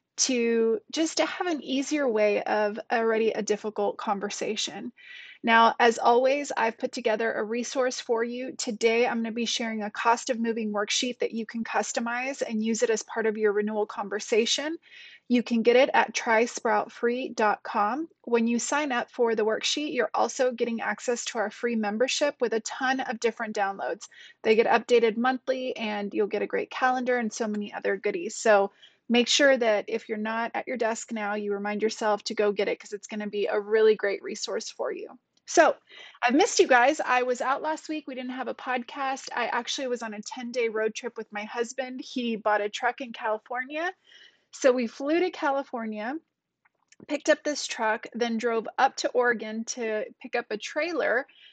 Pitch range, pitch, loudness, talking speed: 220-260 Hz, 235 Hz, -27 LUFS, 195 wpm